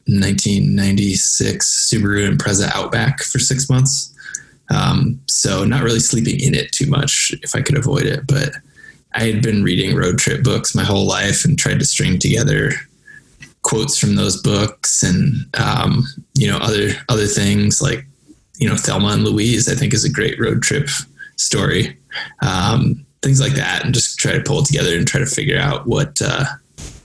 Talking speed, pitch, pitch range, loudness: 175 wpm, 135 Hz, 110-140 Hz, -16 LUFS